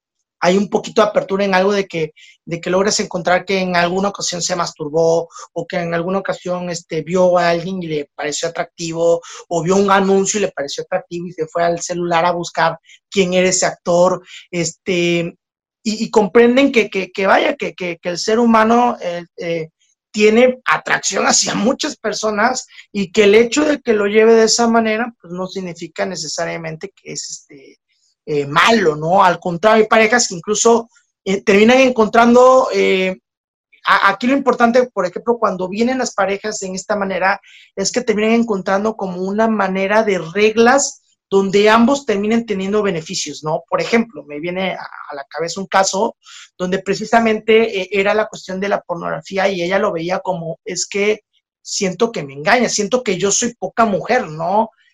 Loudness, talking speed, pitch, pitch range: -16 LUFS, 185 wpm, 195 Hz, 175-220 Hz